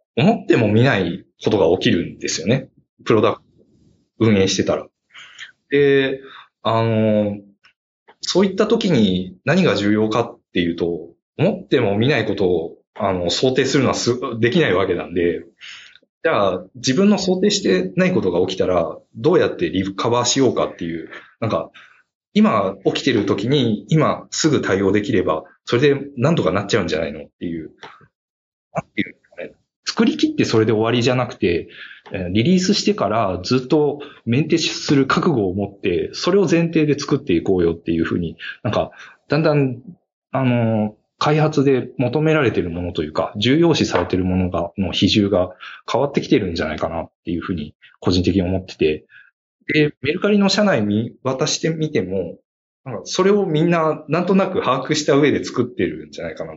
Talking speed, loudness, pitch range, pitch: 340 characters per minute, -19 LUFS, 100-160 Hz, 130 Hz